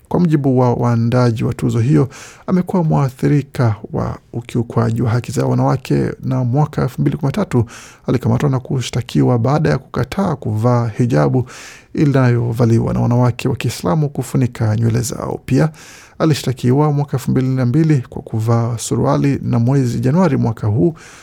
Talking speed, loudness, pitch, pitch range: 135 wpm, -16 LUFS, 125 Hz, 120-145 Hz